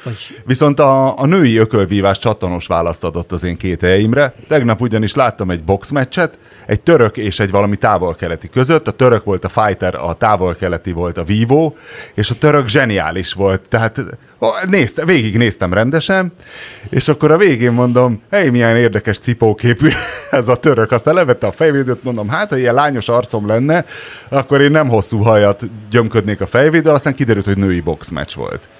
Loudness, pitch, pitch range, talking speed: -13 LUFS, 115 Hz, 100-135 Hz, 165 wpm